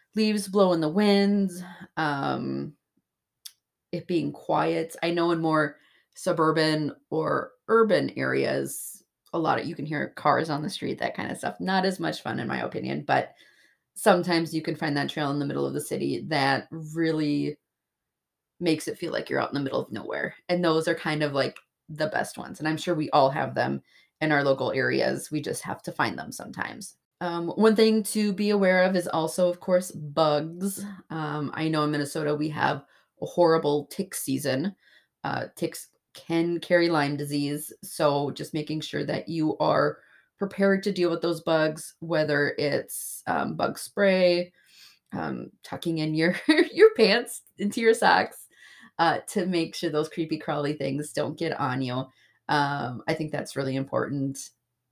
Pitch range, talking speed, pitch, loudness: 145-180 Hz, 180 wpm, 160 Hz, -26 LUFS